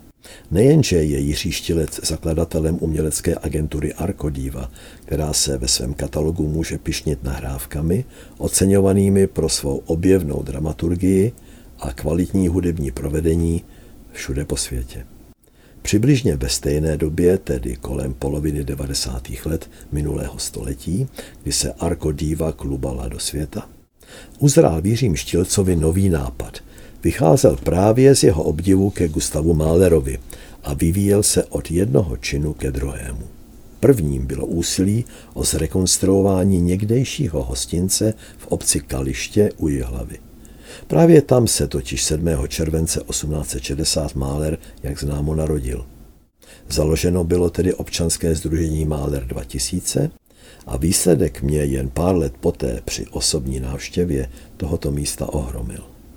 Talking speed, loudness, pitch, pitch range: 115 wpm, -19 LUFS, 80 Hz, 70-90 Hz